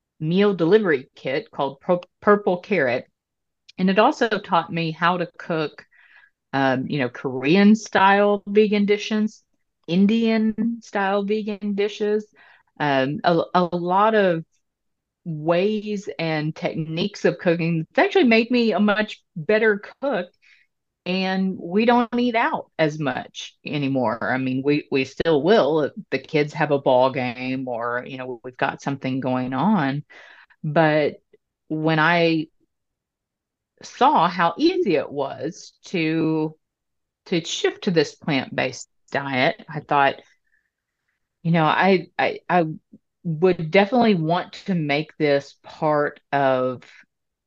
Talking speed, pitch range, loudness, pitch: 130 wpm, 145-210 Hz, -21 LUFS, 170 Hz